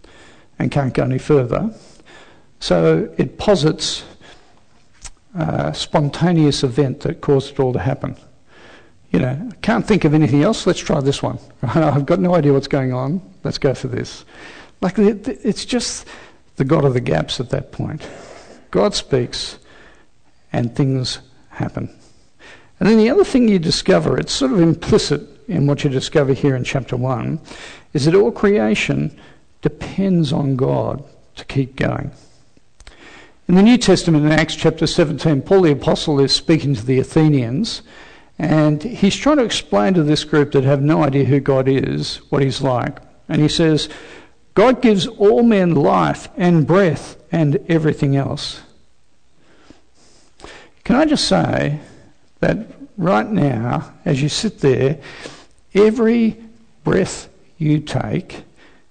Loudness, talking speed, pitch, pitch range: -17 LUFS, 150 wpm, 150 Hz, 135-185 Hz